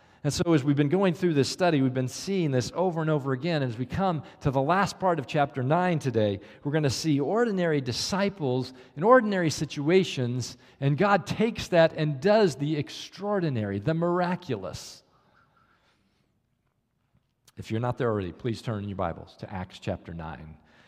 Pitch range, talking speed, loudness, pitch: 125-175 Hz, 175 wpm, -26 LUFS, 145 Hz